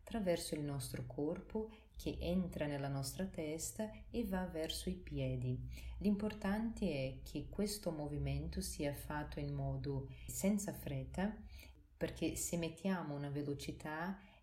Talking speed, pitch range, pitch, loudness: 125 wpm, 145-190 Hz, 160 Hz, -42 LUFS